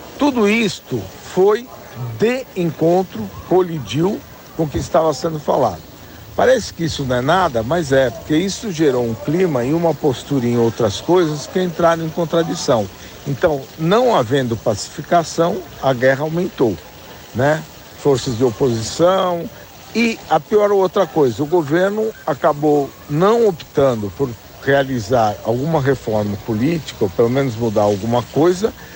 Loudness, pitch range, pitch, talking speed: -17 LUFS, 125-180 Hz, 155 Hz, 140 wpm